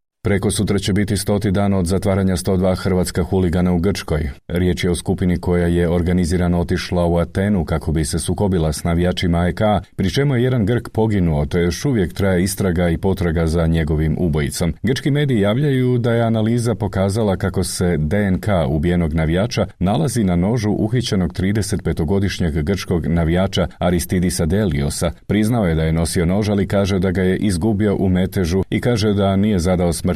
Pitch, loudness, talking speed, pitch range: 95 Hz, -18 LUFS, 175 wpm, 85-100 Hz